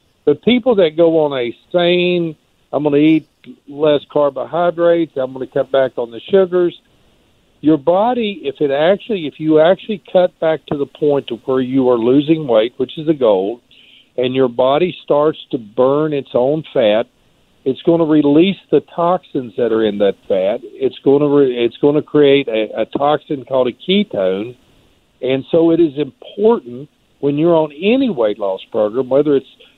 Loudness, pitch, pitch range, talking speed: -15 LUFS, 145 Hz, 130-170 Hz, 185 wpm